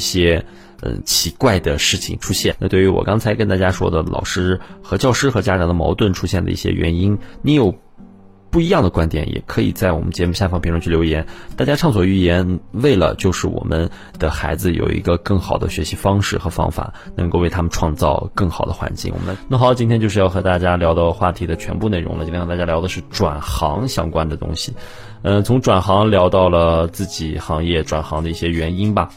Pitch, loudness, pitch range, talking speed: 90 Hz, -18 LUFS, 85-100 Hz, 325 characters per minute